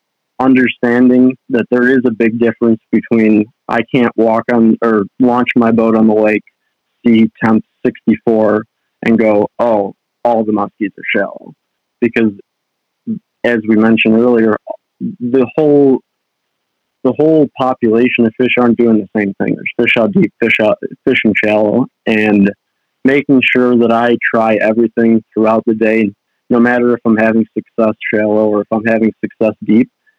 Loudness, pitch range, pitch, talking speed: -12 LUFS, 110-125 Hz, 115 Hz, 155 wpm